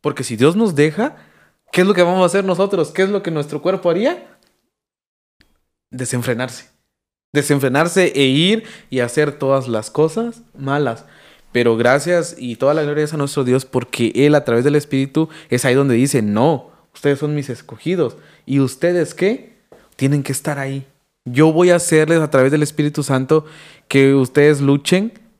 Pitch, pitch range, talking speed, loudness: 145 Hz, 135-170 Hz, 175 wpm, -16 LUFS